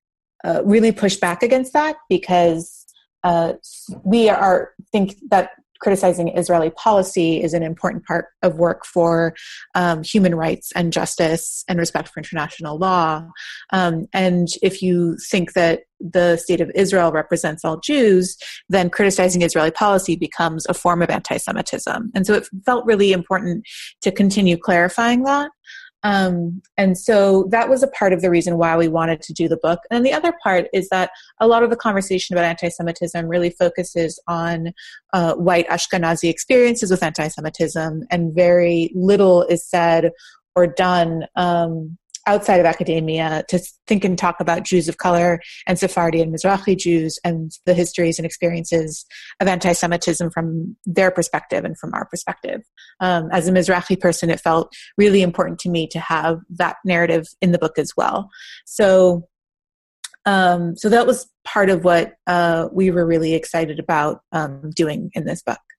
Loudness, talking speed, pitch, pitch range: -18 LUFS, 165 wpm, 175 Hz, 165-190 Hz